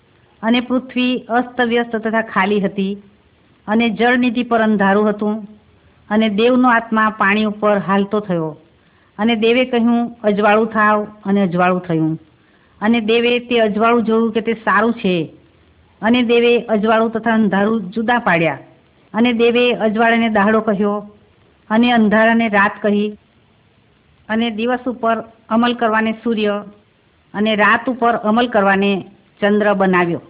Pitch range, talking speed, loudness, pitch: 200-230 Hz, 125 wpm, -16 LUFS, 220 Hz